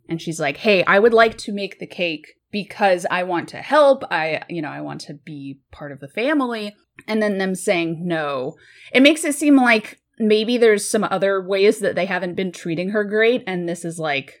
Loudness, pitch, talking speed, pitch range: -19 LUFS, 195 Hz, 220 wpm, 165-225 Hz